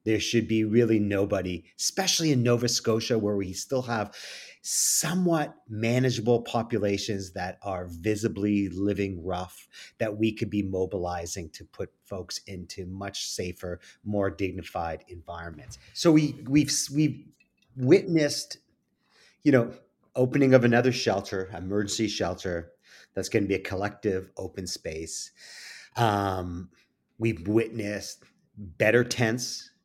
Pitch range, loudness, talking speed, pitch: 95-120 Hz, -27 LUFS, 125 wpm, 105 Hz